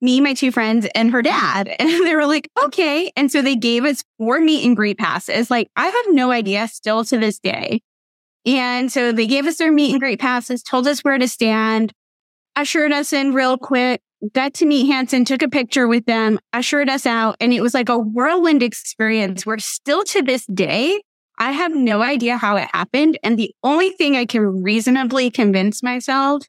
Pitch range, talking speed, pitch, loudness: 225-285 Hz, 205 wpm, 255 Hz, -17 LUFS